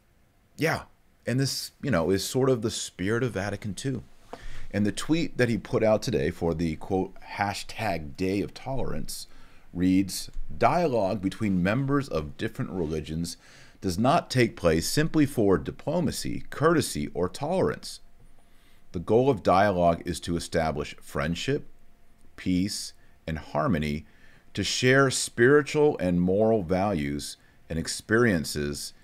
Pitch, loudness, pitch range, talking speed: 95 Hz, -27 LUFS, 85-120 Hz, 130 wpm